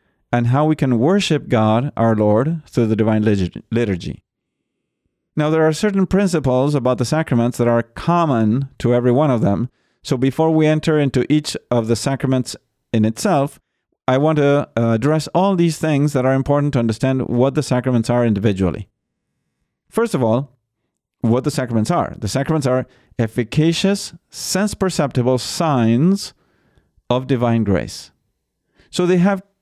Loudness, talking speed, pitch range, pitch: -18 LUFS, 155 wpm, 120-155 Hz, 130 Hz